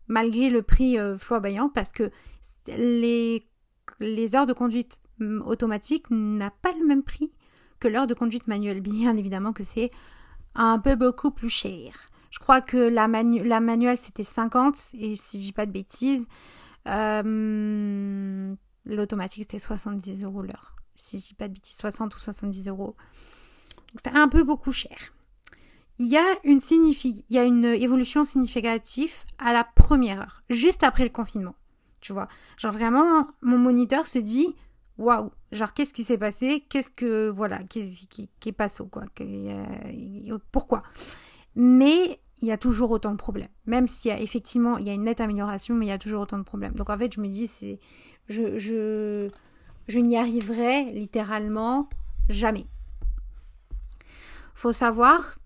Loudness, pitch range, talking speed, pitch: -24 LUFS, 210-245 Hz, 170 wpm, 230 Hz